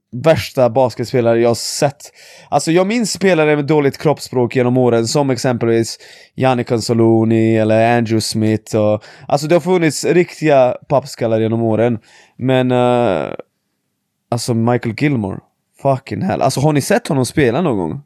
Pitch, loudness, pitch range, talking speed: 125 Hz, -15 LUFS, 115-140 Hz, 150 wpm